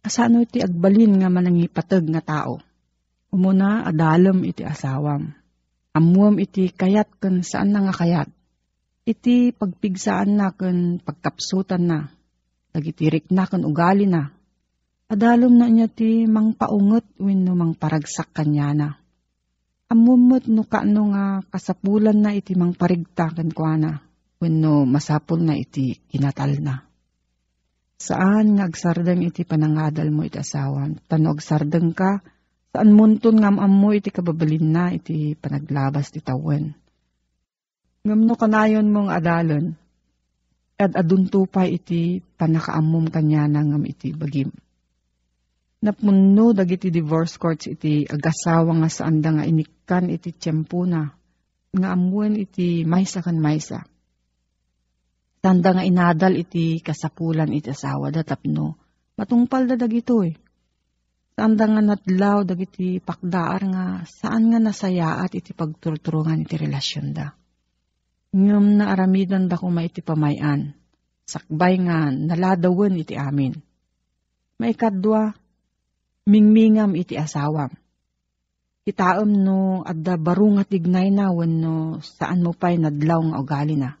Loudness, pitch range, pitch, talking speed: -20 LUFS, 145-195 Hz, 170 Hz, 120 wpm